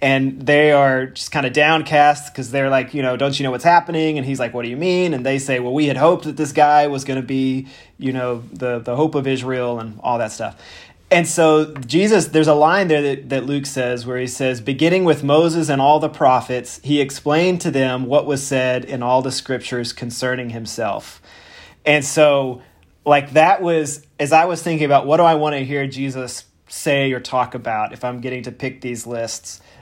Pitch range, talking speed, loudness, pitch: 125-150 Hz, 225 wpm, -18 LUFS, 135 Hz